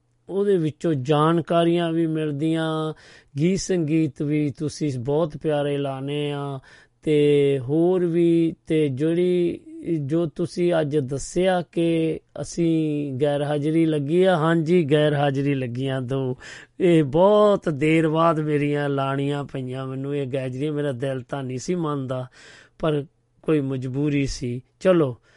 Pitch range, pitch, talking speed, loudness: 140-165 Hz, 150 Hz, 130 wpm, -22 LUFS